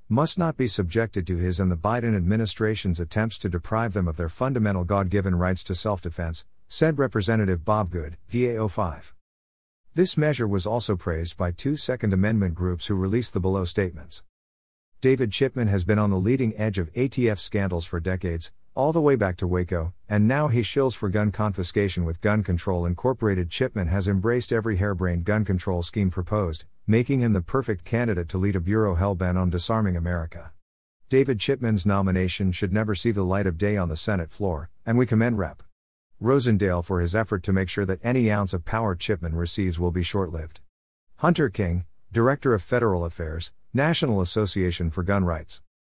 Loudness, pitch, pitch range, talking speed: -25 LUFS, 100 Hz, 90-110 Hz, 180 wpm